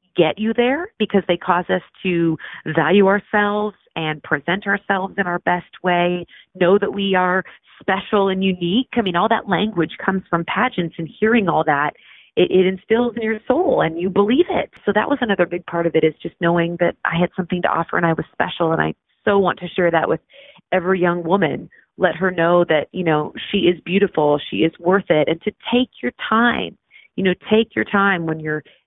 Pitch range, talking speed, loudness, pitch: 170-200 Hz, 215 wpm, -19 LUFS, 185 Hz